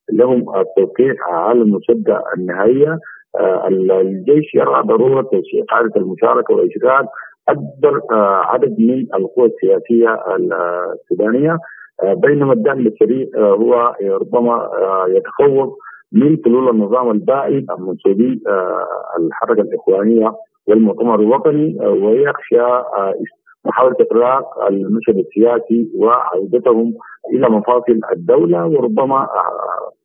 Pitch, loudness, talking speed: 150 Hz, -14 LUFS, 85 wpm